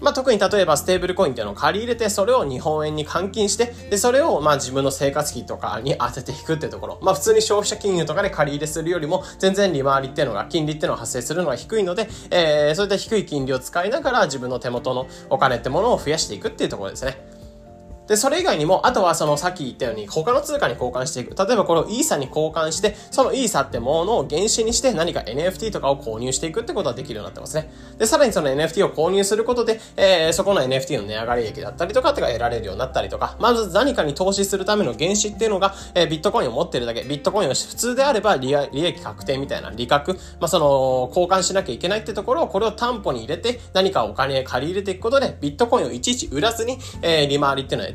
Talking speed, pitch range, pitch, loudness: 540 characters per minute, 140-210 Hz, 180 Hz, -21 LUFS